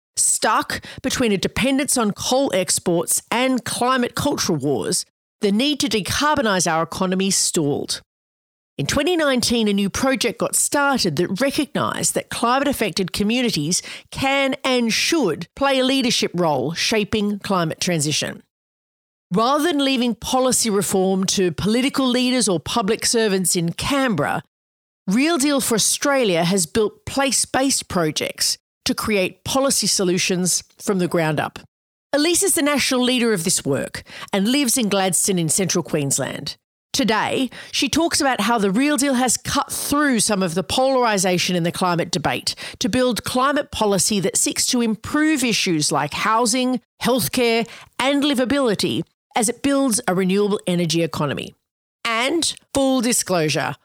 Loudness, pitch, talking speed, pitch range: -19 LUFS, 225 Hz, 145 wpm, 185-265 Hz